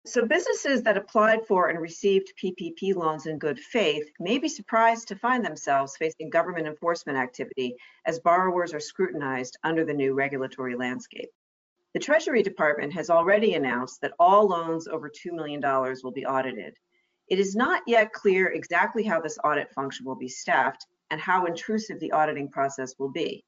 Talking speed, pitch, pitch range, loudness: 170 wpm, 165 Hz, 145-210 Hz, -26 LUFS